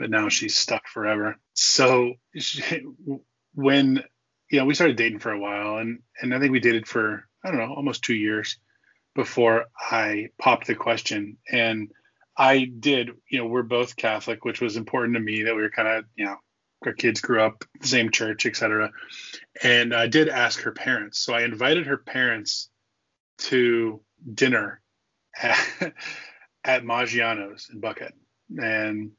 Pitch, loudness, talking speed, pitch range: 120 Hz, -23 LUFS, 170 wpm, 110-130 Hz